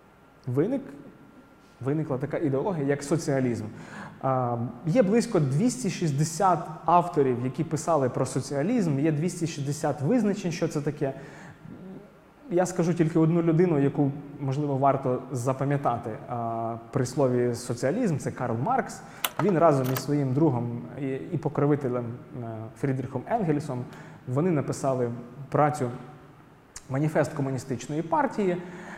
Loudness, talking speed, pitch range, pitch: -27 LUFS, 105 wpm, 130-165 Hz, 145 Hz